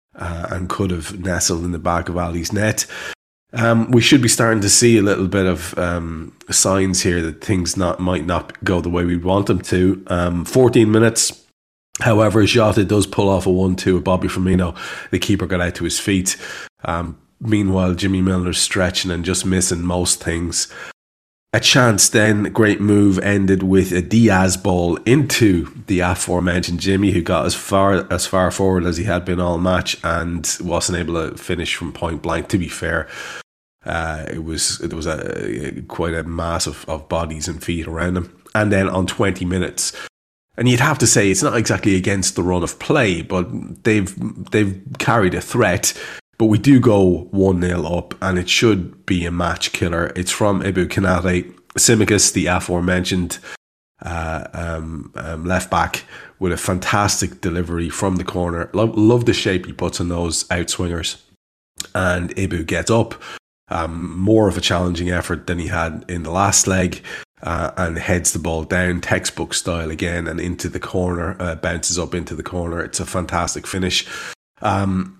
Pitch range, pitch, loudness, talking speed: 85-100 Hz, 90 Hz, -18 LUFS, 185 wpm